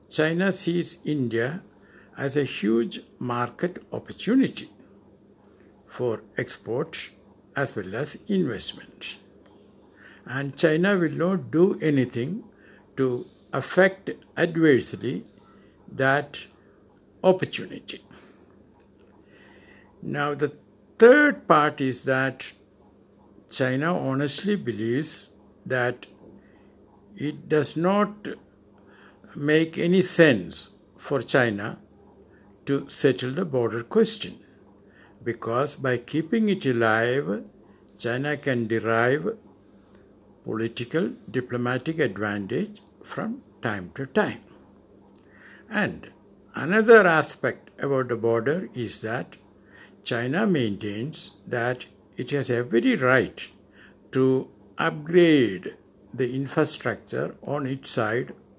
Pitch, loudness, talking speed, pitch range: 135 Hz, -24 LUFS, 85 wpm, 120-165 Hz